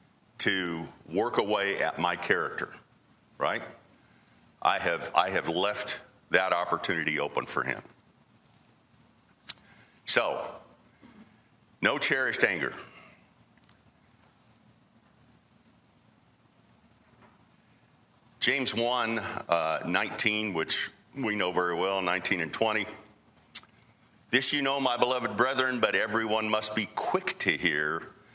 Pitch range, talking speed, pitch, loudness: 105-120 Hz, 95 wpm, 110 Hz, -29 LUFS